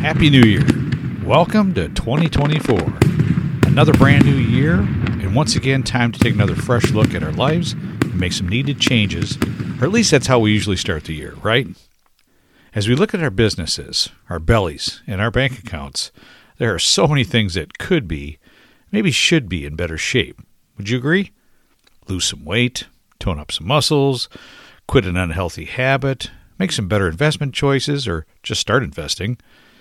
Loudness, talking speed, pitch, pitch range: -17 LUFS, 175 wpm, 120 Hz, 95-140 Hz